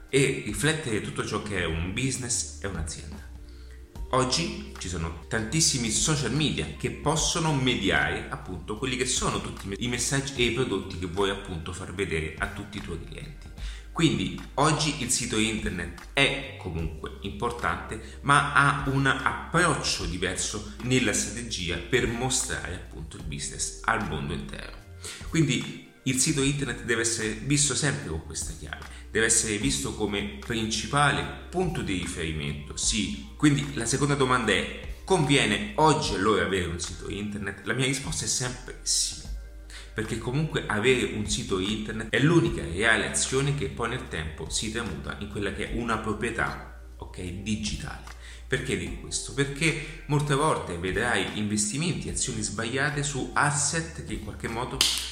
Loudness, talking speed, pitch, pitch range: -27 LUFS, 150 wpm, 105 Hz, 80-130 Hz